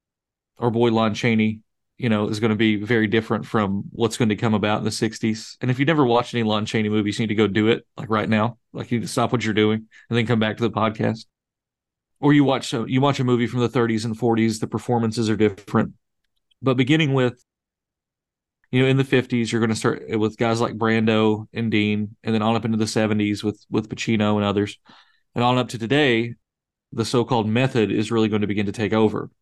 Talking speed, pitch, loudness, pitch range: 240 wpm, 115 Hz, -21 LUFS, 110-120 Hz